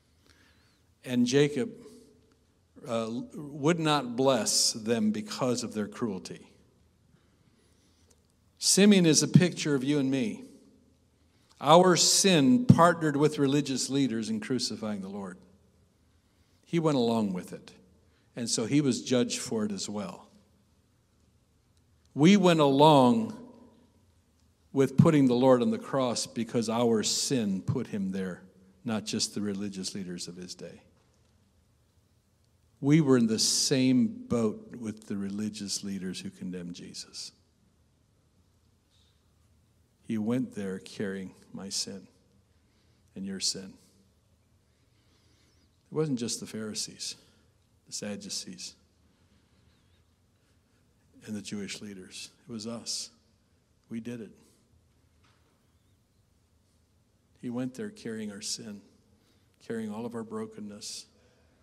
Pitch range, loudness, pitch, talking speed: 95-140 Hz, -27 LUFS, 110 Hz, 115 wpm